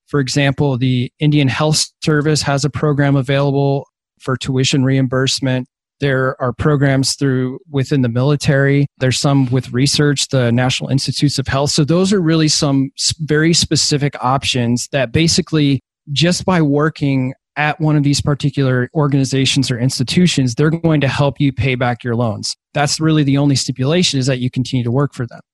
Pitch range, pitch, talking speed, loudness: 130-150 Hz, 140 Hz, 170 wpm, -15 LUFS